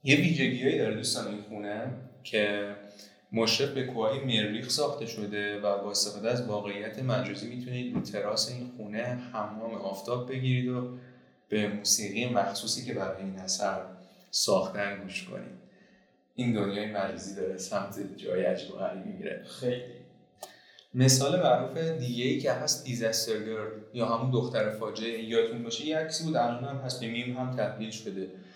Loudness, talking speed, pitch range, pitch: -30 LUFS, 145 wpm, 105-125 Hz, 115 Hz